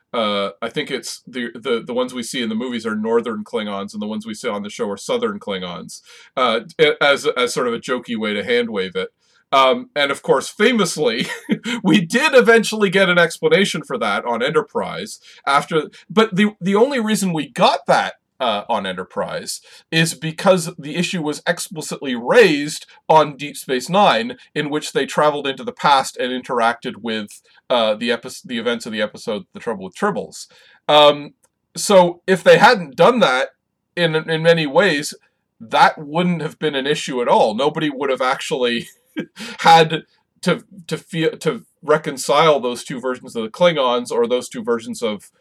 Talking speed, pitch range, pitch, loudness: 185 wpm, 145-225 Hz, 170 Hz, -18 LUFS